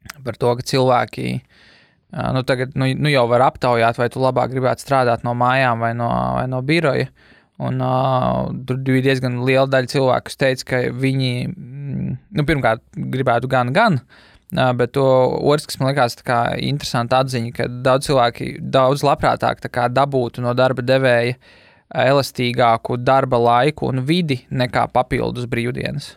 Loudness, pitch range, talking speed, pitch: -18 LUFS, 120-135 Hz, 150 wpm, 130 Hz